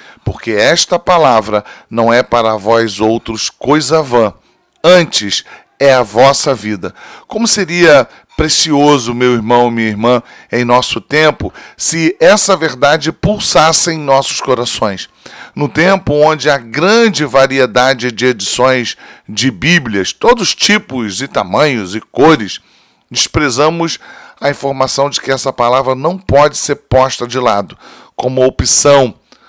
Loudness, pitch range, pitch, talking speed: -11 LUFS, 120-155 Hz, 135 Hz, 130 wpm